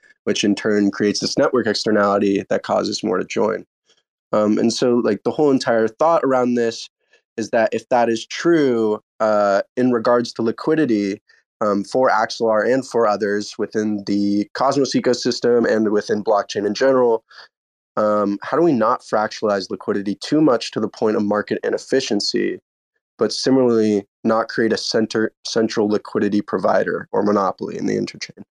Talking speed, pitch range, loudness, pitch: 160 wpm, 105-125 Hz, -19 LUFS, 110 Hz